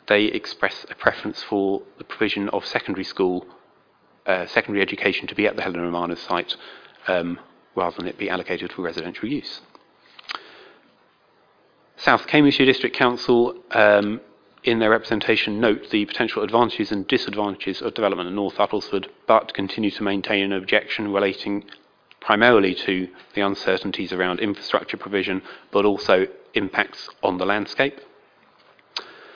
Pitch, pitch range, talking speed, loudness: 100 Hz, 95-105 Hz, 140 wpm, -22 LUFS